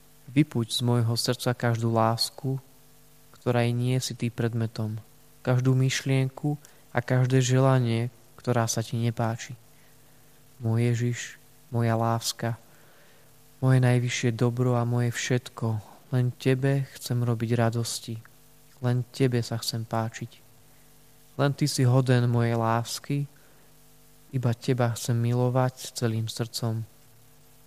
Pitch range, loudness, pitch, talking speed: 115-135 Hz, -27 LUFS, 125 Hz, 115 wpm